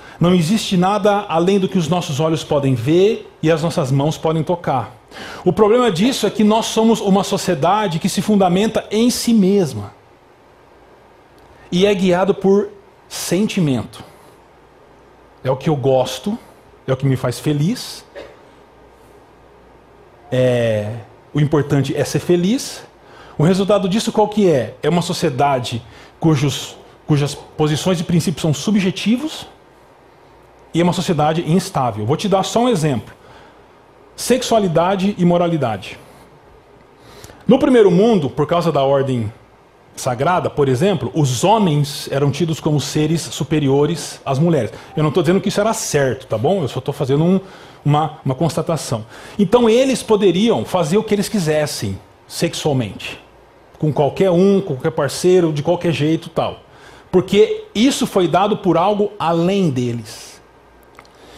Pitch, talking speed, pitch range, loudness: 170 Hz, 145 wpm, 145-200 Hz, -17 LUFS